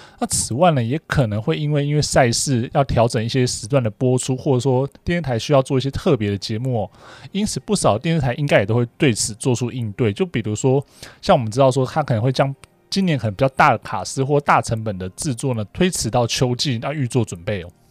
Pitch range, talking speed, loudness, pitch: 120-145 Hz, 340 characters per minute, -19 LUFS, 130 Hz